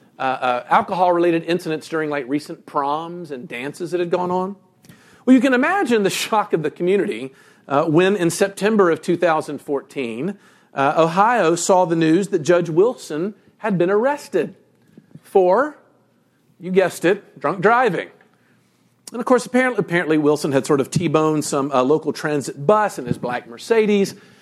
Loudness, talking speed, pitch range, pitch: -19 LUFS, 160 wpm, 150-200 Hz, 175 Hz